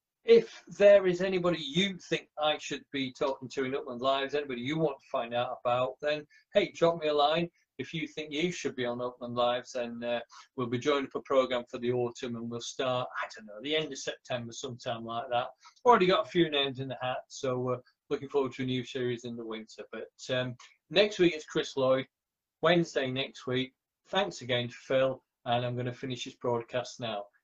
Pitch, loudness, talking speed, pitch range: 130 Hz, -31 LUFS, 225 wpm, 125-155 Hz